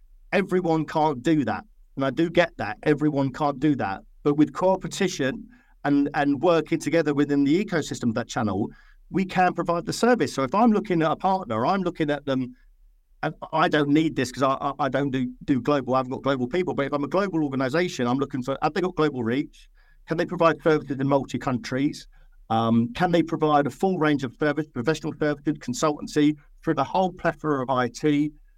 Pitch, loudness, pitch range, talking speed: 150 Hz, -24 LUFS, 135-165 Hz, 205 wpm